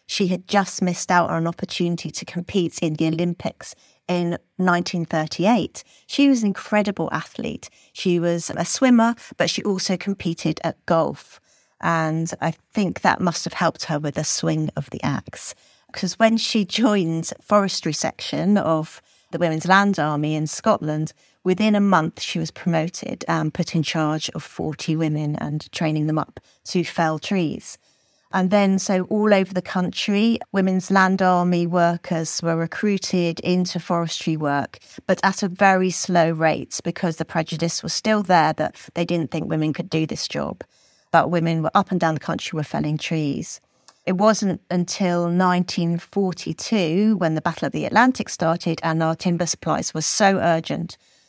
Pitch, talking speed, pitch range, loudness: 175 Hz, 165 wpm, 160-195 Hz, -21 LUFS